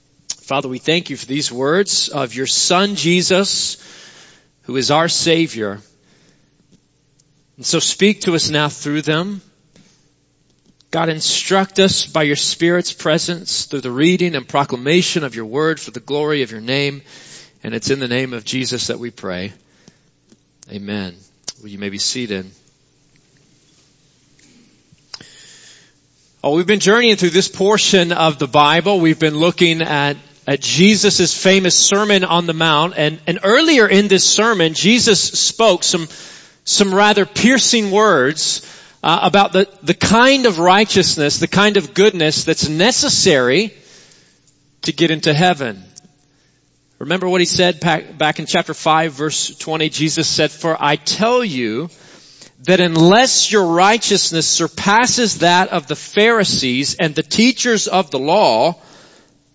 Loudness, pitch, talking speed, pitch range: -14 LUFS, 165 Hz, 145 wpm, 145-190 Hz